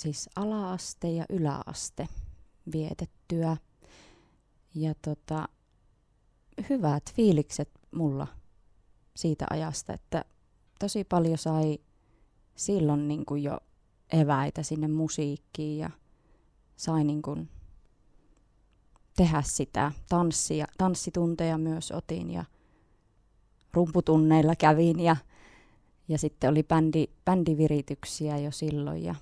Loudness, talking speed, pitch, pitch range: -29 LUFS, 90 wpm, 155 Hz, 140-165 Hz